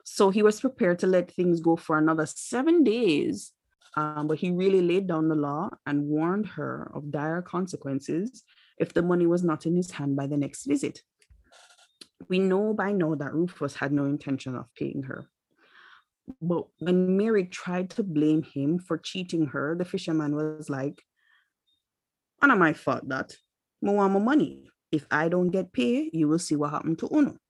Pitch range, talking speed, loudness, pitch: 150-190 Hz, 185 wpm, -27 LUFS, 170 Hz